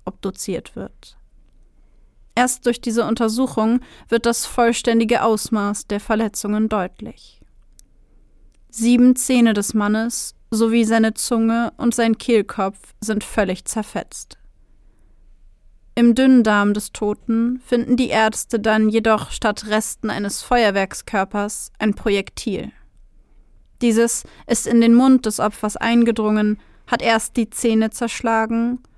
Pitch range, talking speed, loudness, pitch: 210-235 Hz, 115 wpm, -19 LUFS, 225 Hz